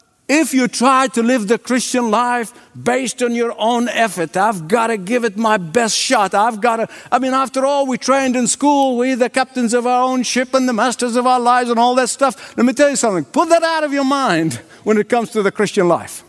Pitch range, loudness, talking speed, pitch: 230-260 Hz, -16 LUFS, 245 wpm, 245 Hz